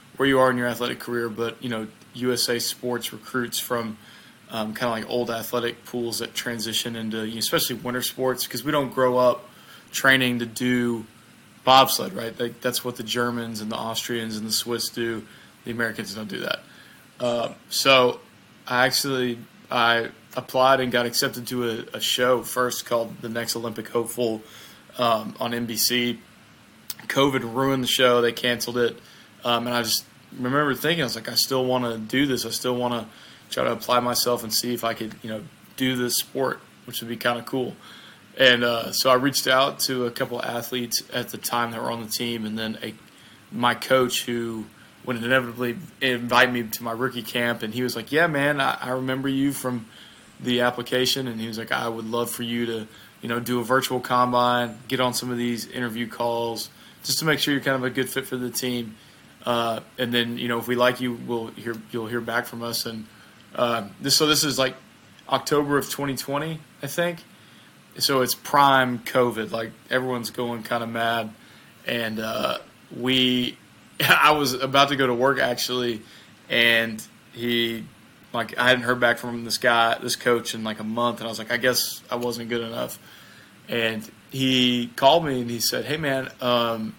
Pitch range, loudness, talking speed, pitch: 115-125 Hz, -23 LUFS, 200 wpm, 120 Hz